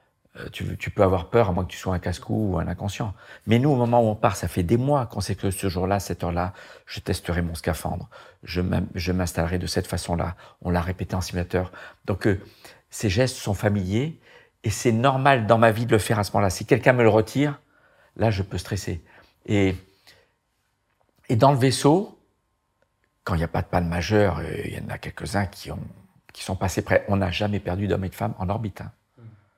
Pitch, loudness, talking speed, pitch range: 100 Hz, -24 LUFS, 225 wpm, 90-115 Hz